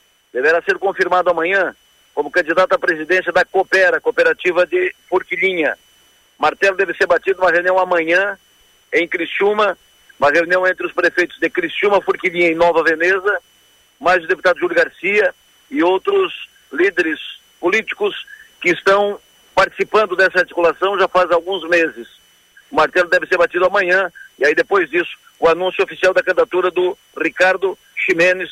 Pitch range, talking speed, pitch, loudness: 180-205 Hz, 145 wpm, 185 Hz, -16 LUFS